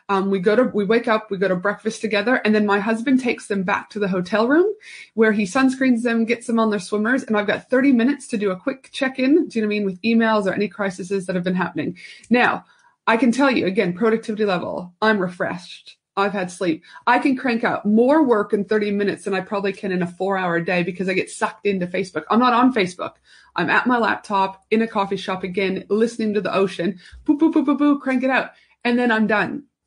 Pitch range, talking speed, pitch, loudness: 195-245 Hz, 245 wpm, 215 Hz, -20 LUFS